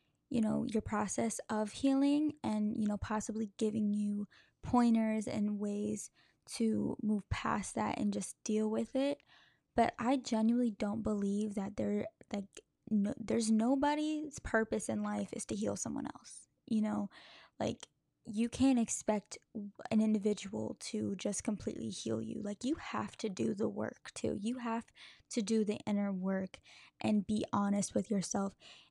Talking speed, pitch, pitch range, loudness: 160 wpm, 215 Hz, 205-230 Hz, -36 LUFS